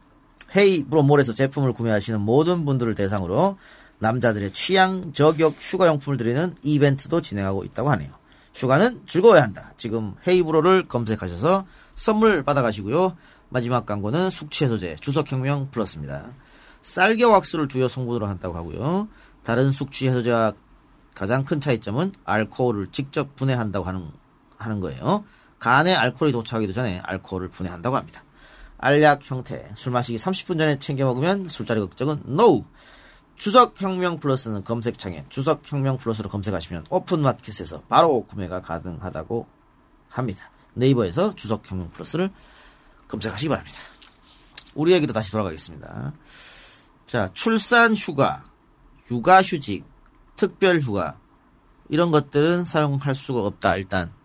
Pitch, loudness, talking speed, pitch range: 130 Hz, -22 LUFS, 345 characters per minute, 105-160 Hz